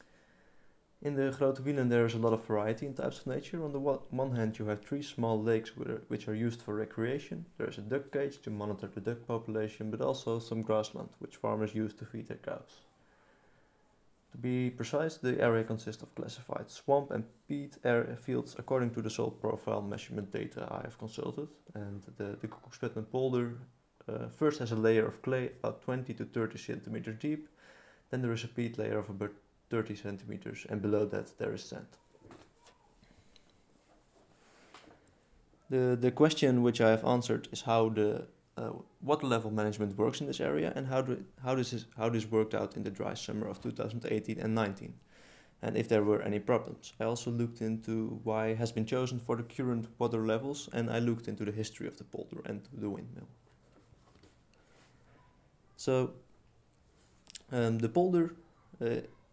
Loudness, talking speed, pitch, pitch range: -35 LUFS, 185 wpm, 115 Hz, 110-130 Hz